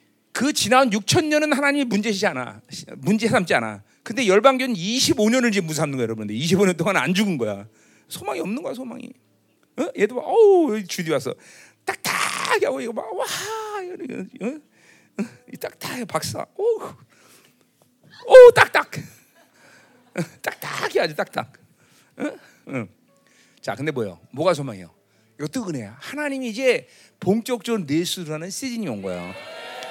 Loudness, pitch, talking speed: -20 LUFS, 215 Hz, 265 characters per minute